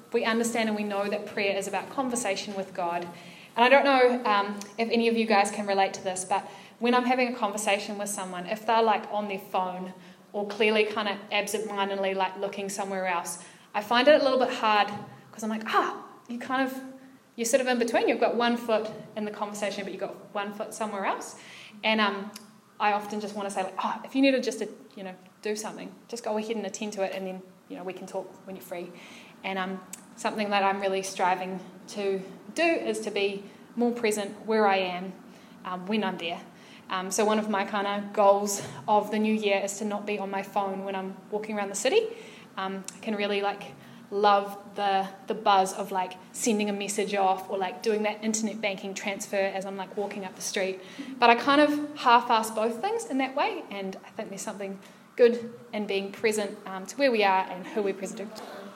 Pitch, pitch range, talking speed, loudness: 205 Hz, 195-220 Hz, 225 wpm, -27 LUFS